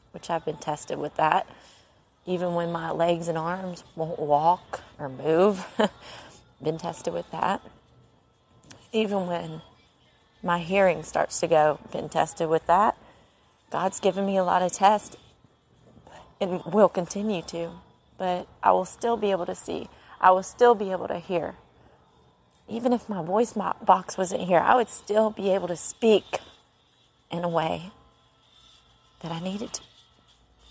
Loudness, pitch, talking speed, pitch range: -25 LUFS, 180 Hz, 150 wpm, 165-195 Hz